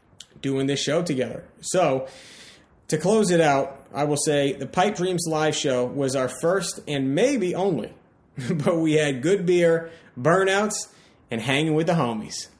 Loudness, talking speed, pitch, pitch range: -23 LUFS, 160 wpm, 155 Hz, 135-180 Hz